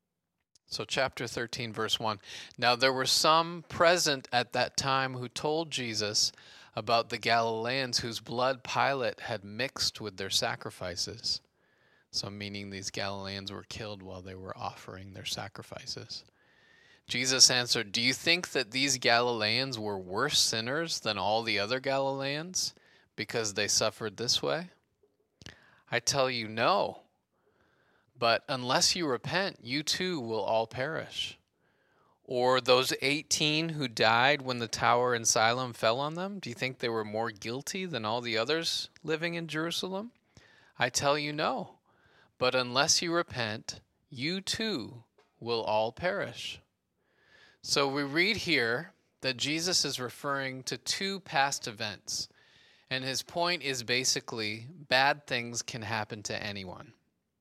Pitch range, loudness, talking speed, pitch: 115-145 Hz, -30 LUFS, 140 wpm, 125 Hz